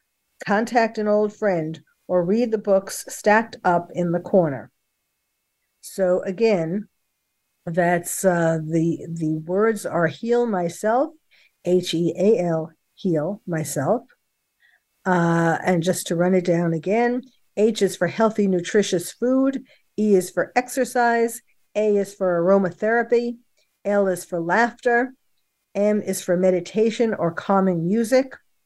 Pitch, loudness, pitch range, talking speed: 195 Hz, -21 LUFS, 175-225 Hz, 130 wpm